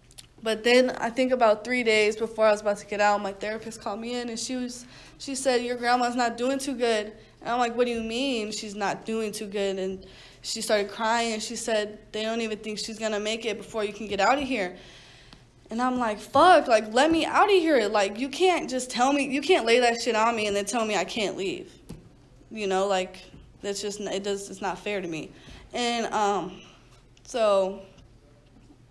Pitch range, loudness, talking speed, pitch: 205-245 Hz, -25 LUFS, 225 wpm, 220 Hz